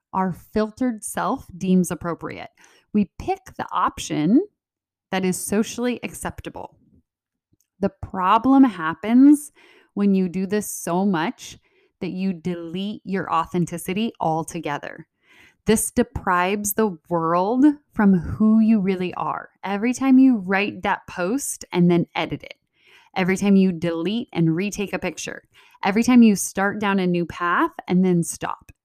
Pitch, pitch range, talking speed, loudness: 195 Hz, 180-235 Hz, 135 wpm, -21 LUFS